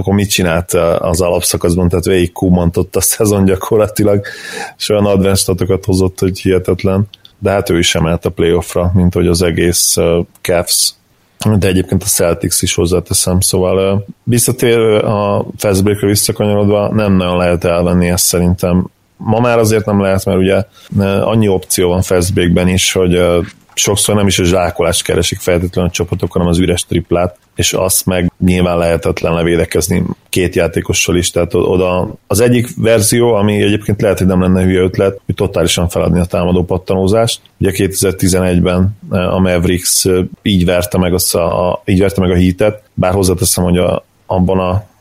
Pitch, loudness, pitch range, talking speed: 95 Hz, -12 LUFS, 90-100 Hz, 165 wpm